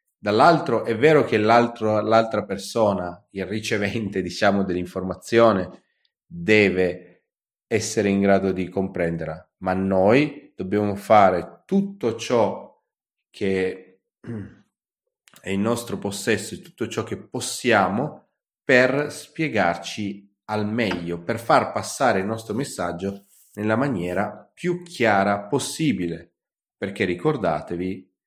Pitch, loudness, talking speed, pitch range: 100 Hz, -22 LUFS, 105 wpm, 95-115 Hz